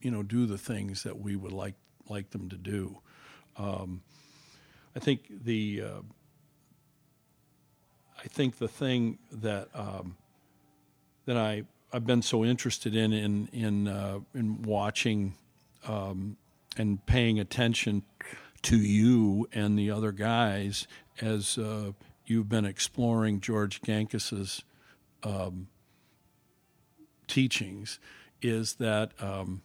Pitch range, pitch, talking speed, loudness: 100-120 Hz, 110 Hz, 115 wpm, -31 LUFS